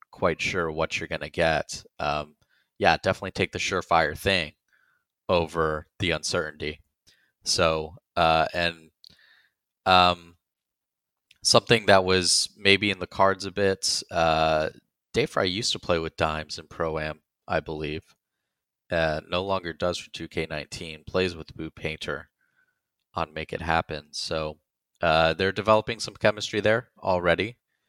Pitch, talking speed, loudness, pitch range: 85 Hz, 135 wpm, -25 LUFS, 80-95 Hz